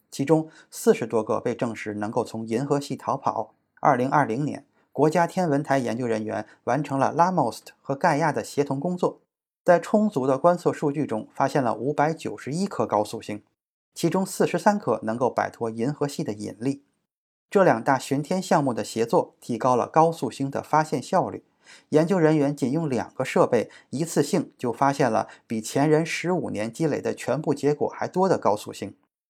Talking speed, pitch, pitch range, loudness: 285 characters per minute, 140 Hz, 115-160 Hz, -24 LUFS